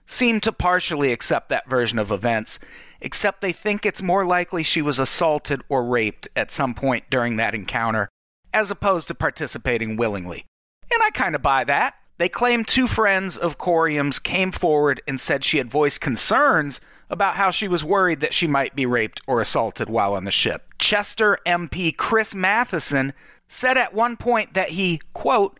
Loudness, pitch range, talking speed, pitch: -21 LUFS, 135-200 Hz, 180 wpm, 170 Hz